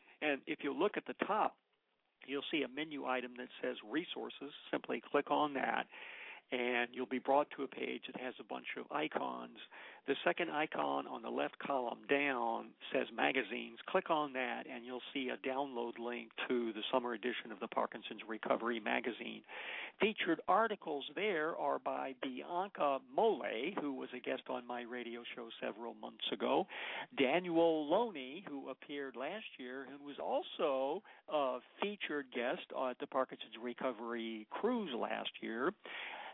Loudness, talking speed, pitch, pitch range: -39 LUFS, 160 wpm, 130 Hz, 120-140 Hz